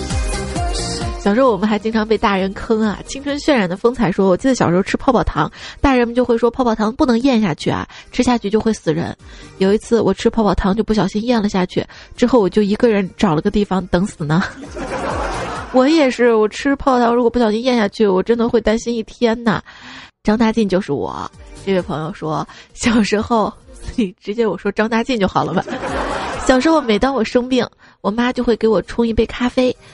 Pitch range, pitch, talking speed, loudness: 200-245 Hz, 220 Hz, 310 characters per minute, -17 LUFS